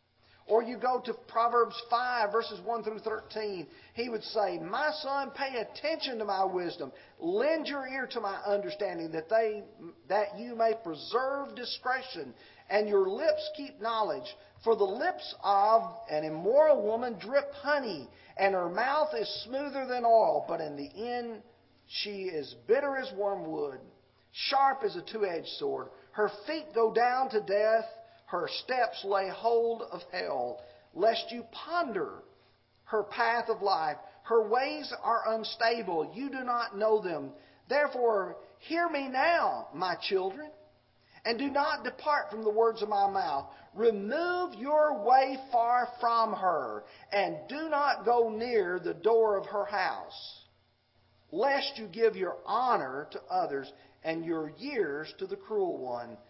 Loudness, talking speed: -31 LUFS, 150 wpm